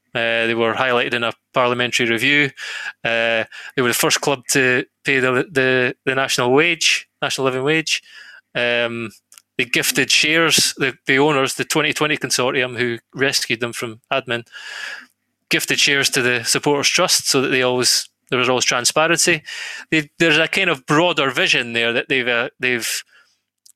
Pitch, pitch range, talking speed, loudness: 130 Hz, 120-145 Hz, 165 wpm, -17 LUFS